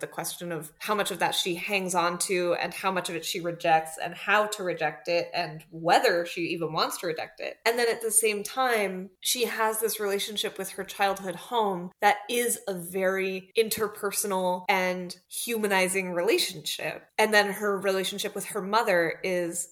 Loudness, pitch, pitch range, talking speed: -27 LUFS, 195 Hz, 175-210 Hz, 185 wpm